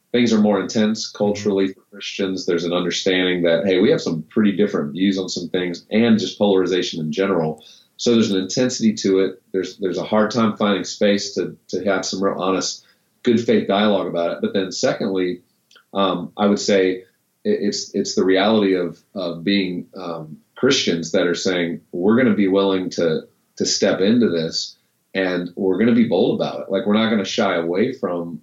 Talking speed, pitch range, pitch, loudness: 205 wpm, 90-105 Hz, 95 Hz, -19 LUFS